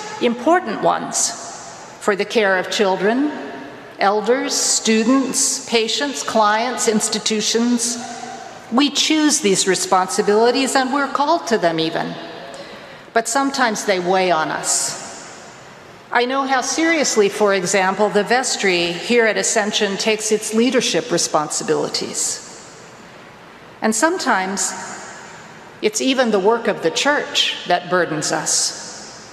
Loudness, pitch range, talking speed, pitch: -17 LUFS, 195-260 Hz, 115 wpm, 220 Hz